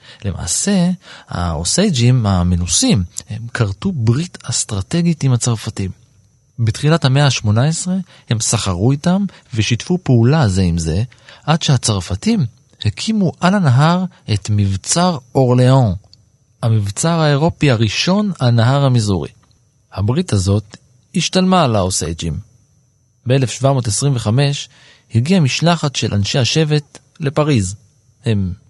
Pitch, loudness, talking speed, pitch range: 125 Hz, -16 LUFS, 95 wpm, 105-145 Hz